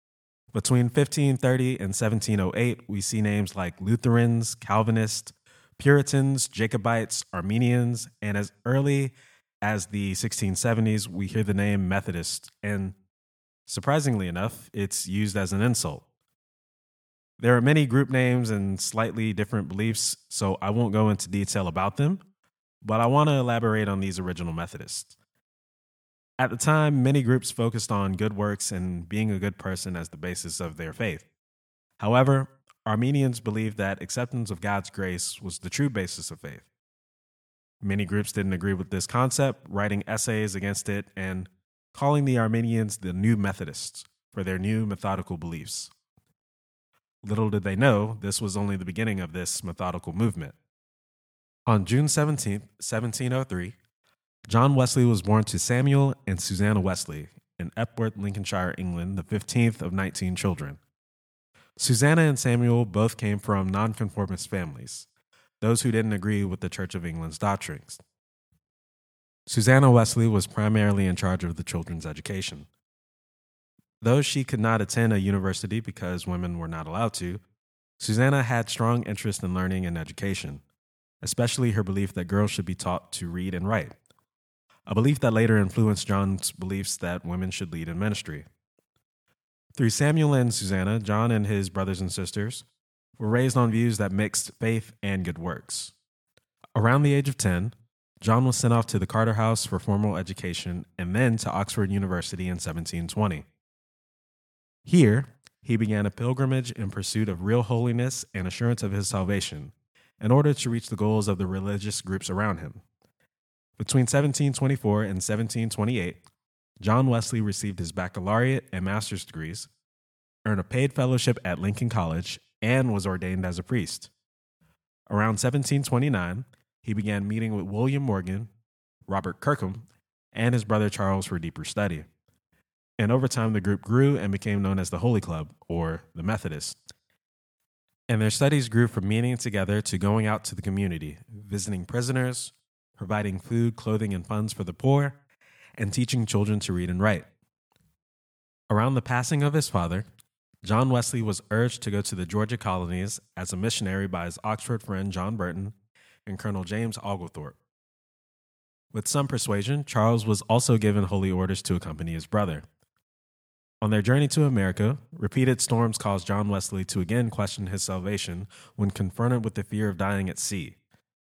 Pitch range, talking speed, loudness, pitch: 95-120 Hz, 160 wpm, -26 LUFS, 105 Hz